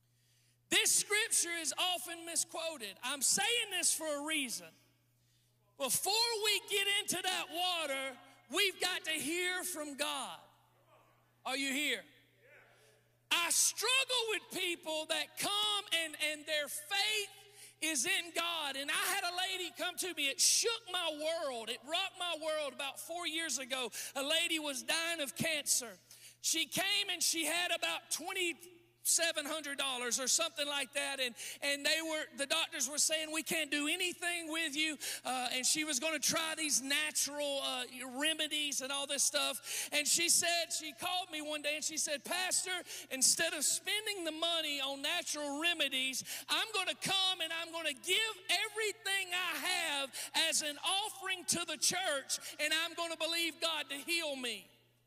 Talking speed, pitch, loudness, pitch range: 170 wpm, 320 Hz, -34 LUFS, 285-355 Hz